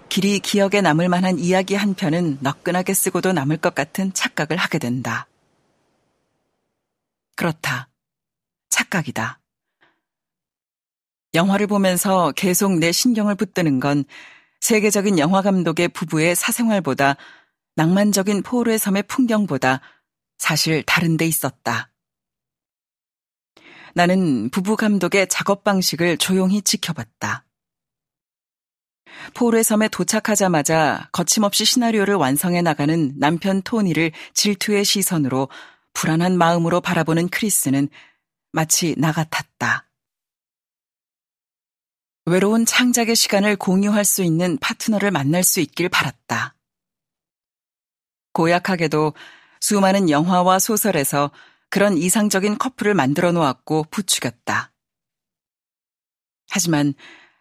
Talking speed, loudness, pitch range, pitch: 250 characters per minute, -19 LUFS, 160-205 Hz, 185 Hz